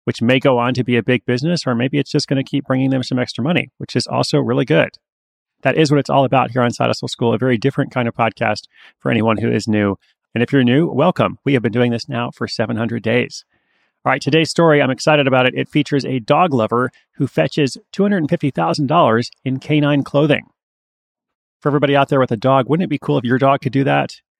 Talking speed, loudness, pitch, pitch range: 240 wpm, -17 LUFS, 130 Hz, 120-145 Hz